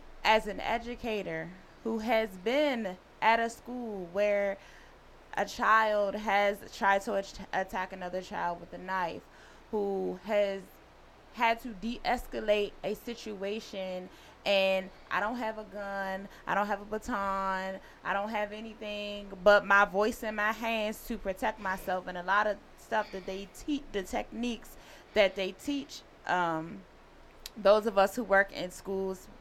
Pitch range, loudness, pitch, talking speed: 190-220 Hz, -31 LUFS, 205 Hz, 150 wpm